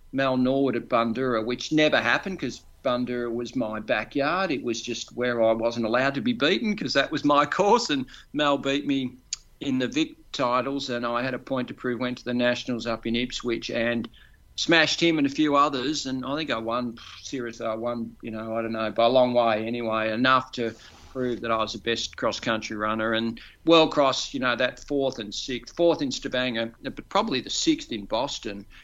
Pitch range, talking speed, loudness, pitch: 115-135 Hz, 215 wpm, -25 LUFS, 120 Hz